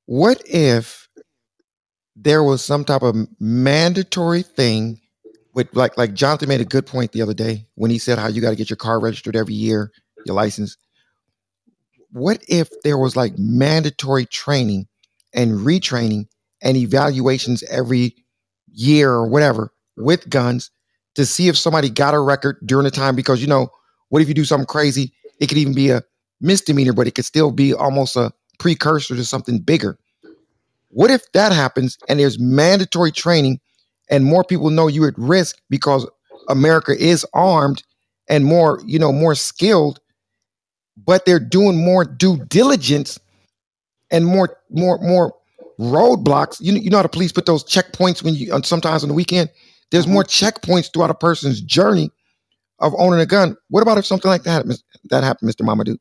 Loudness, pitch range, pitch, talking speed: -16 LUFS, 120-170 Hz, 140 Hz, 175 wpm